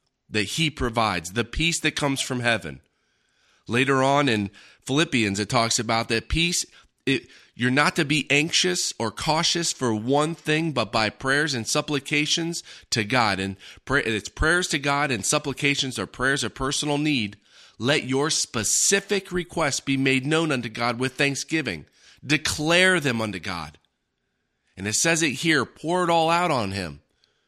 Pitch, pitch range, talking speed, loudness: 135 Hz, 110-155 Hz, 165 wpm, -23 LUFS